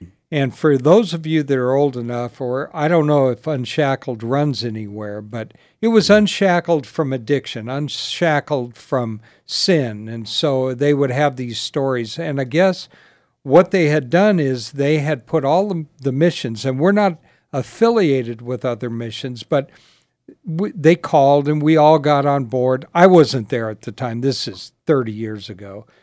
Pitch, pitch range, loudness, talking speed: 140 Hz, 120-160 Hz, -18 LUFS, 175 wpm